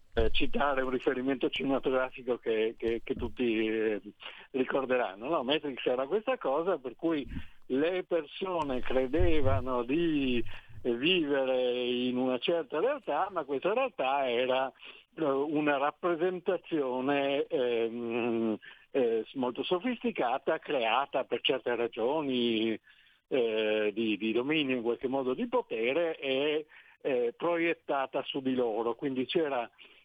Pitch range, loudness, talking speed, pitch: 120-160 Hz, -31 LUFS, 115 wpm, 130 Hz